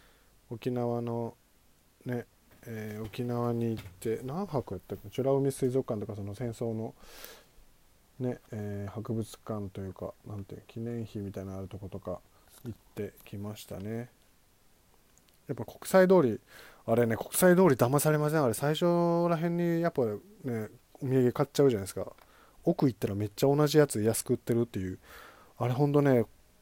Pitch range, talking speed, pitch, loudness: 105-135 Hz, 315 characters per minute, 120 Hz, -30 LUFS